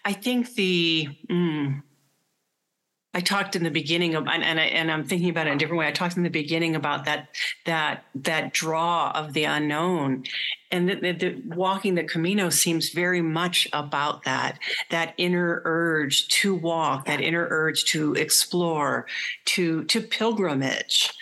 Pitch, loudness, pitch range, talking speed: 165 Hz, -24 LUFS, 155-180 Hz, 170 wpm